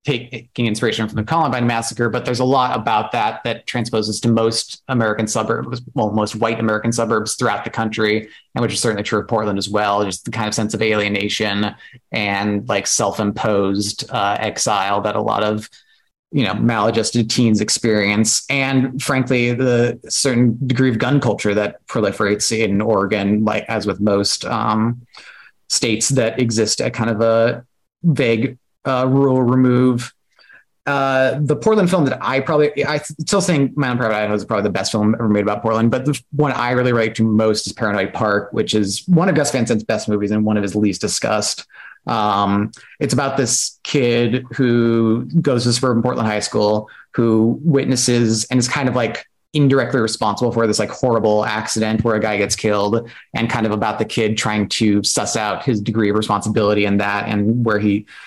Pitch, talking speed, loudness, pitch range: 115 Hz, 190 wpm, -18 LUFS, 105-125 Hz